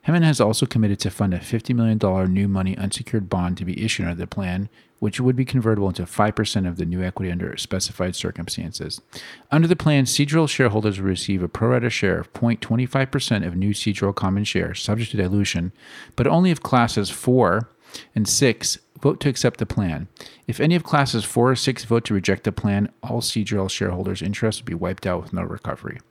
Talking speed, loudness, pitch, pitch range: 200 wpm, -22 LUFS, 105 Hz, 95-125 Hz